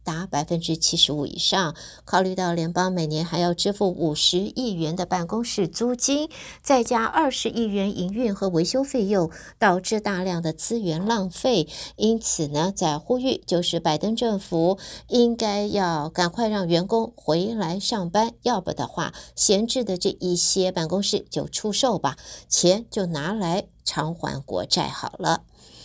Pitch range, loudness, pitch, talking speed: 170-225 Hz, -23 LUFS, 185 Hz, 240 characters per minute